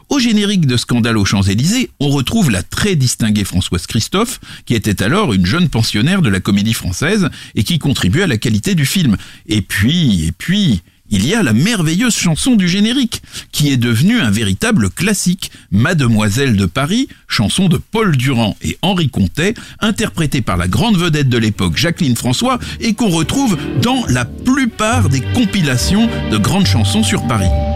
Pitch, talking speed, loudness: 135 Hz, 175 wpm, -14 LUFS